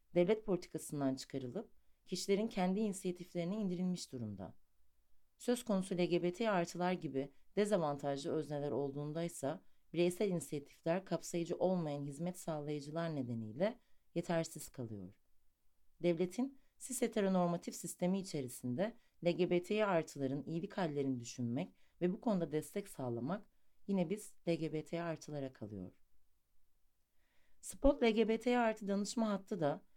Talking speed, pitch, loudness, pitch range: 105 wpm, 170 Hz, -39 LUFS, 135-195 Hz